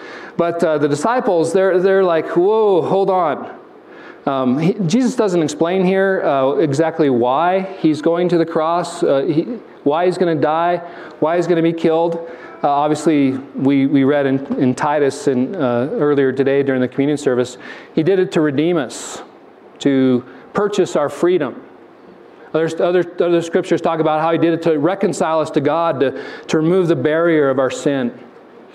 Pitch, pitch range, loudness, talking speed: 165 Hz, 145-175 Hz, -16 LUFS, 180 wpm